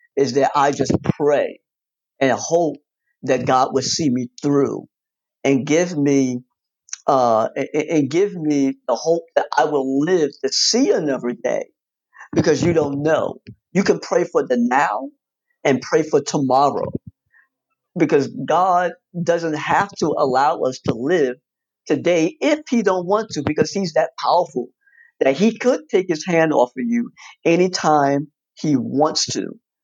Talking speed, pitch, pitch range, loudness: 155 wpm, 165 Hz, 140-215 Hz, -19 LUFS